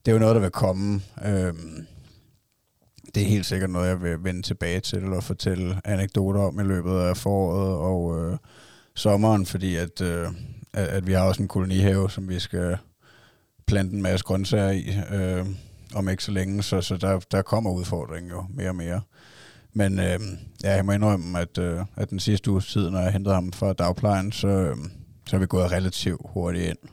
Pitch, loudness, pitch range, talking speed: 95 Hz, -25 LUFS, 90-100 Hz, 195 wpm